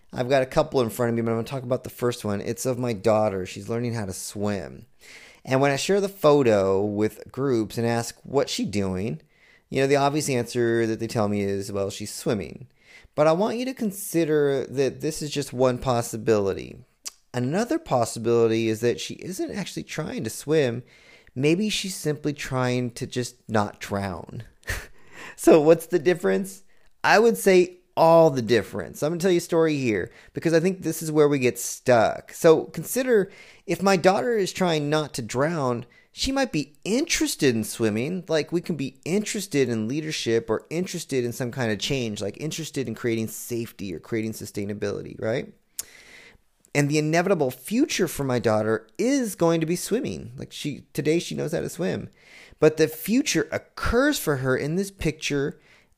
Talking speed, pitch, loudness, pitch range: 190 wpm, 135 Hz, -24 LUFS, 115-165 Hz